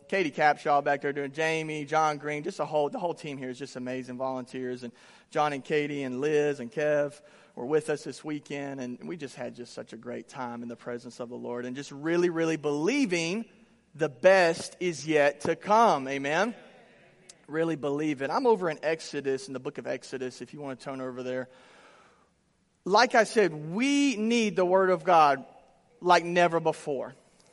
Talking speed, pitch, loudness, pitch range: 195 wpm, 150 Hz, -28 LUFS, 135-170 Hz